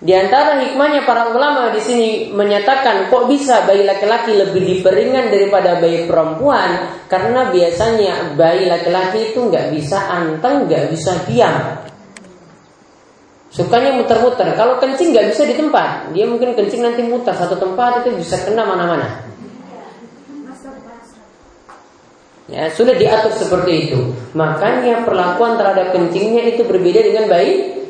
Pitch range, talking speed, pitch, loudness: 180-245 Hz, 130 wpm, 215 Hz, -14 LUFS